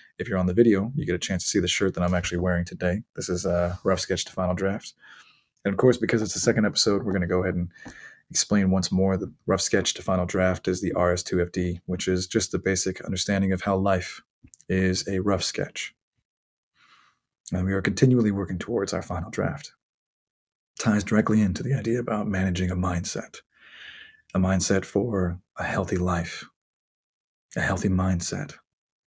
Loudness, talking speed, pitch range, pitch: -25 LUFS, 190 wpm, 90-100 Hz, 95 Hz